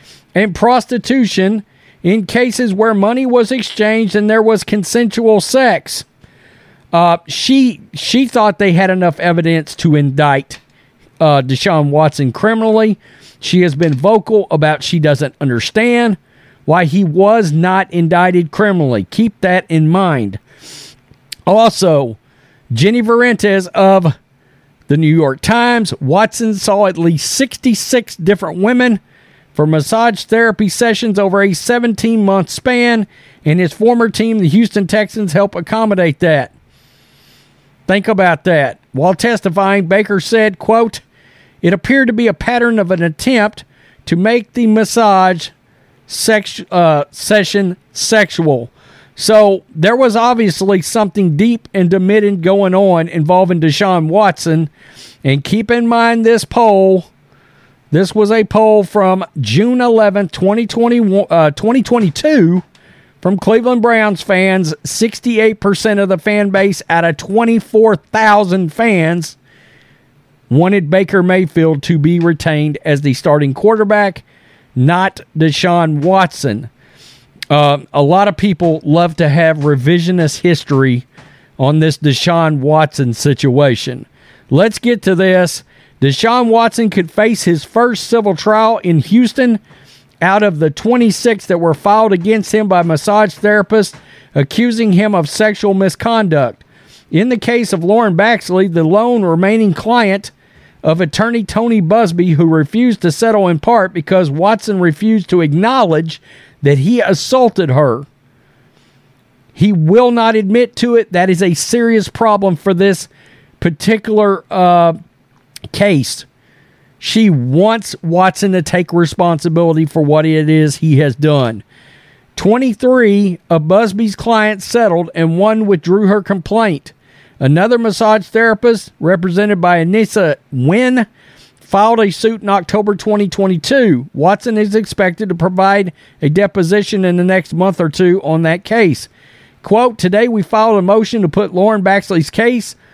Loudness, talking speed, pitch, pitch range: -12 LUFS, 130 wpm, 190 Hz, 155-220 Hz